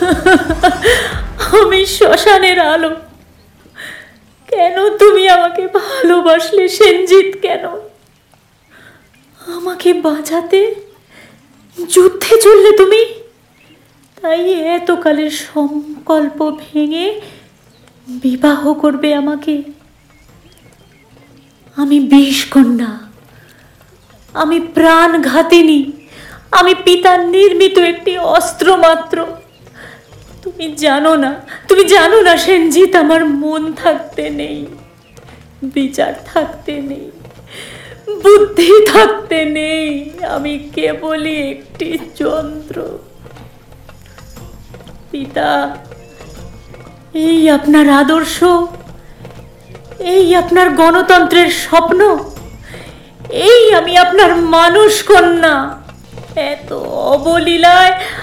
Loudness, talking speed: -10 LUFS, 70 wpm